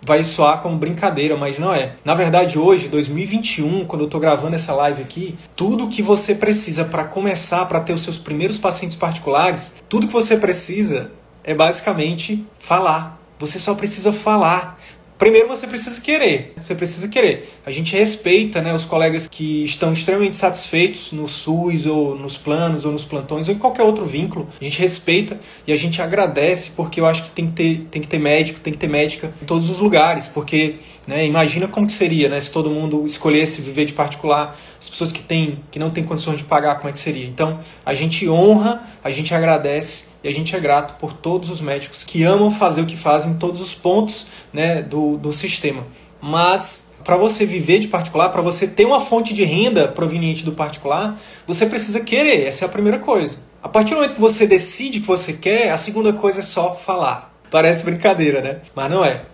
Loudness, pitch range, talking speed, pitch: -17 LUFS, 155-190 Hz, 205 wpm, 165 Hz